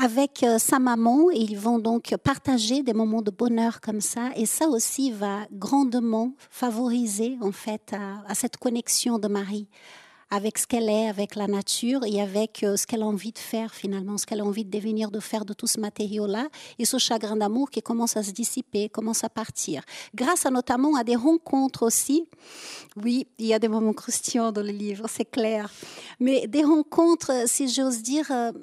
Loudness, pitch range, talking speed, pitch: -25 LUFS, 215-255 Hz, 195 wpm, 230 Hz